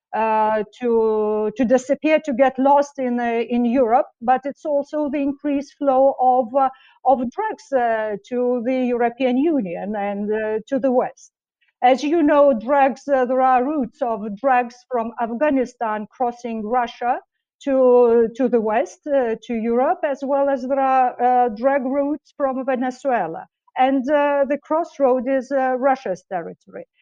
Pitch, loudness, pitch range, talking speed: 260 Hz, -20 LUFS, 240-280 Hz, 155 wpm